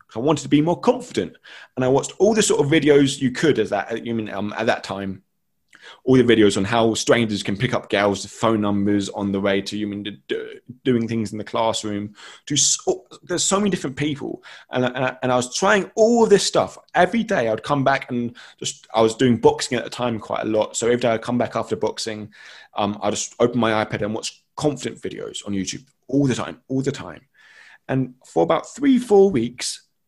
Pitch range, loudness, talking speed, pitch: 105-150 Hz, -21 LUFS, 235 wpm, 120 Hz